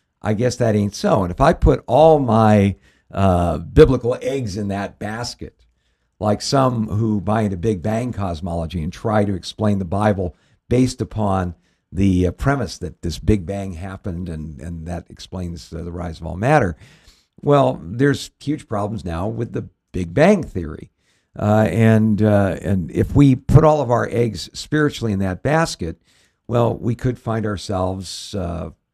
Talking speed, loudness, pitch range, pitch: 170 wpm, -19 LUFS, 90-115 Hz, 105 Hz